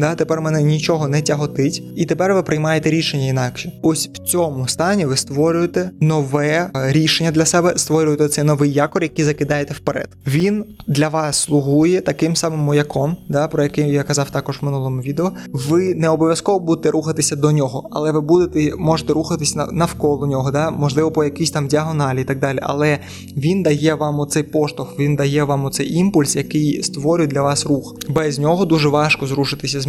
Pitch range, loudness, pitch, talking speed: 145-160 Hz, -17 LUFS, 150 Hz, 180 wpm